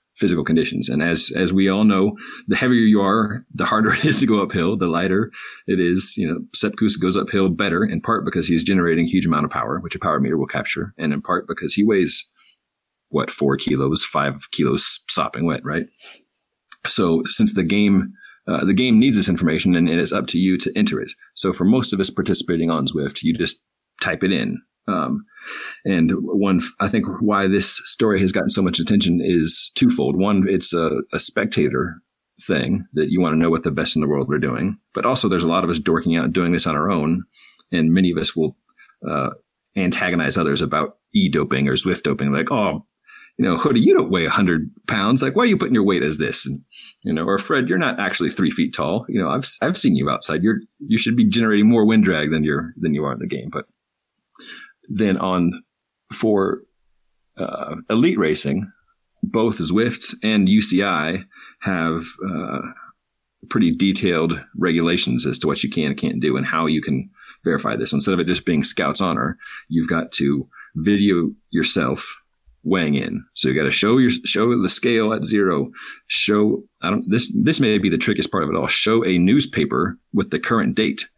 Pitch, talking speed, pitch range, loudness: 95 Hz, 205 wpm, 80-115 Hz, -19 LUFS